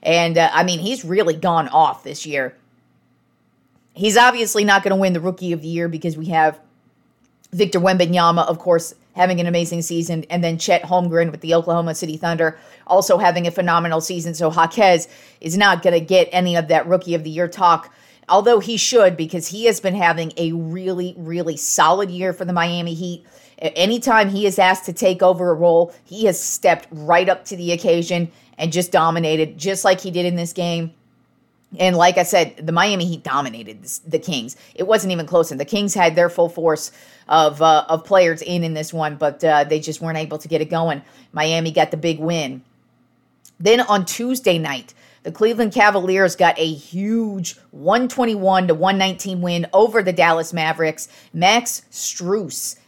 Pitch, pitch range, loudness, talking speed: 170 Hz, 165-190 Hz, -18 LUFS, 190 wpm